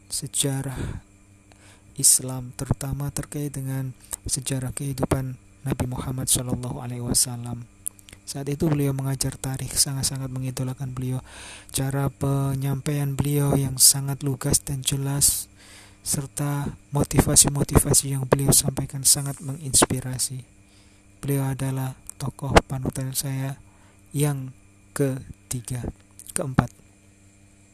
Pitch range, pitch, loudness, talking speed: 100-140 Hz, 130 Hz, -23 LUFS, 90 wpm